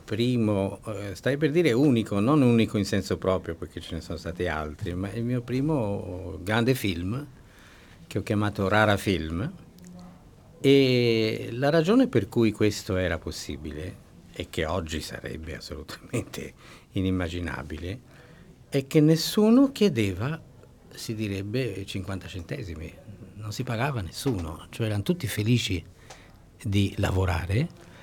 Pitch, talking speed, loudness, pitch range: 105 Hz, 125 wpm, -26 LUFS, 90-125 Hz